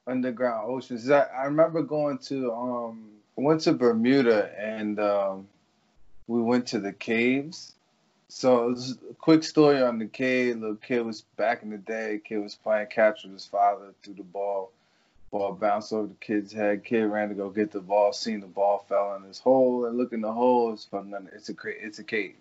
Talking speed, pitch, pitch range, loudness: 205 wpm, 110 Hz, 100-125 Hz, -26 LUFS